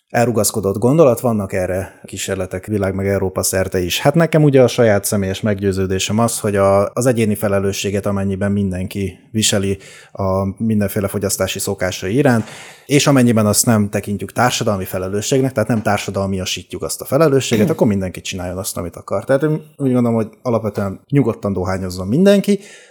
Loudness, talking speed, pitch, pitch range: -17 LUFS, 155 wpm, 100 Hz, 95-120 Hz